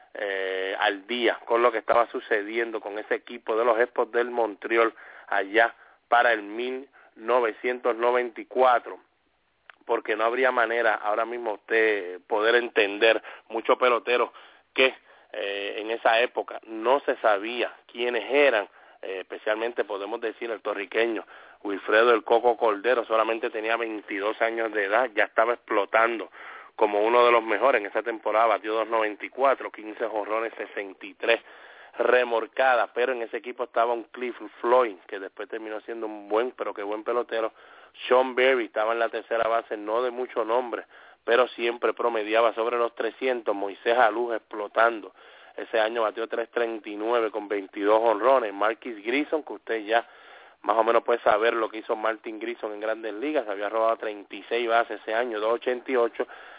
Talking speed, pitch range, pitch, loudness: 155 wpm, 110-120 Hz, 115 Hz, -25 LUFS